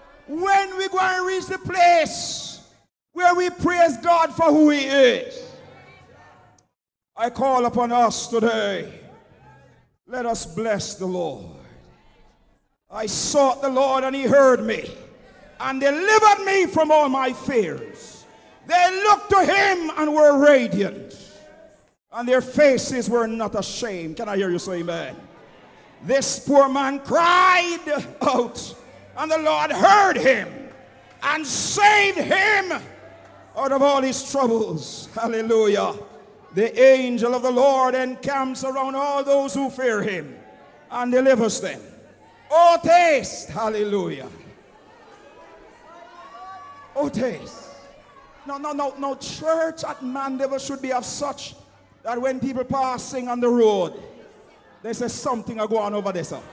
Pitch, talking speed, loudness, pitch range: 270 Hz, 135 wpm, -20 LUFS, 235-320 Hz